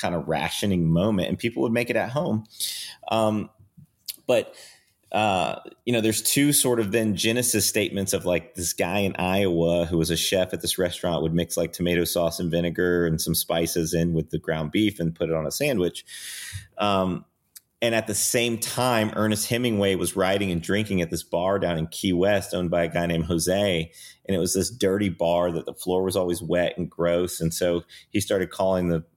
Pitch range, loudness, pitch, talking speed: 85-105 Hz, -24 LUFS, 90 Hz, 210 wpm